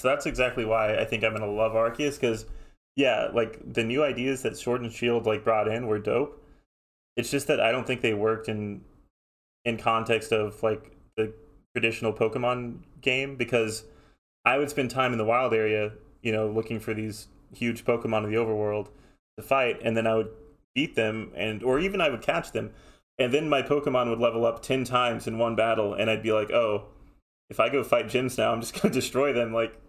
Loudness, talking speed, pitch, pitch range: -27 LUFS, 210 wpm, 115 Hz, 110-125 Hz